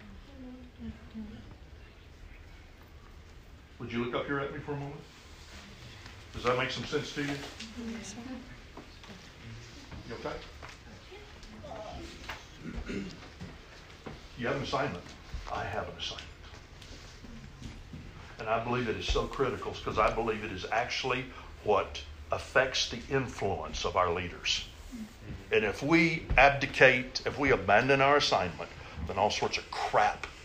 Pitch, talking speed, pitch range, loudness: 110 Hz, 120 wpm, 85-135 Hz, -30 LUFS